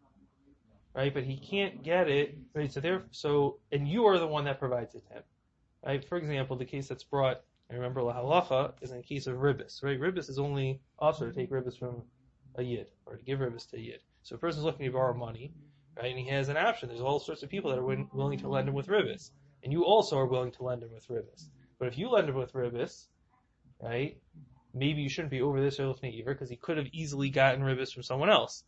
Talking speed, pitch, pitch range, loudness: 250 wpm, 135 Hz, 125-145 Hz, -32 LUFS